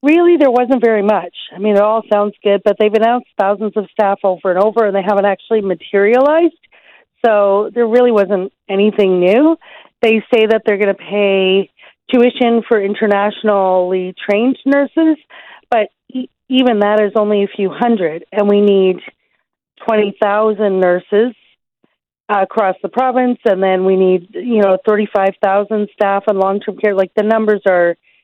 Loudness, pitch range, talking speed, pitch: -13 LUFS, 195-230 Hz, 160 wpm, 210 Hz